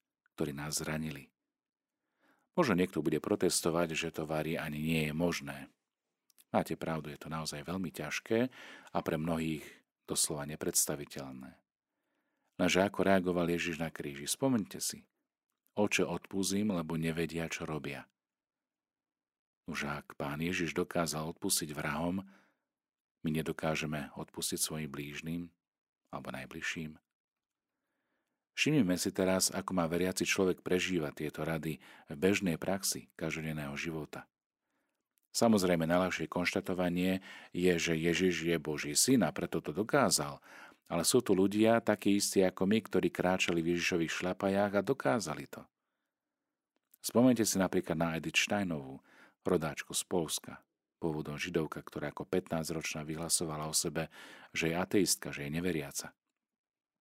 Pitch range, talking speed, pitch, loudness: 80-95 Hz, 125 wpm, 85 Hz, -33 LUFS